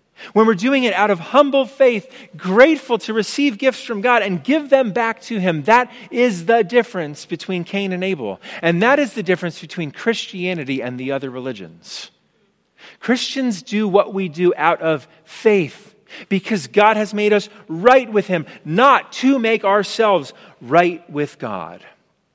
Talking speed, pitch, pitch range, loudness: 165 wpm, 210 Hz, 180-245 Hz, -17 LUFS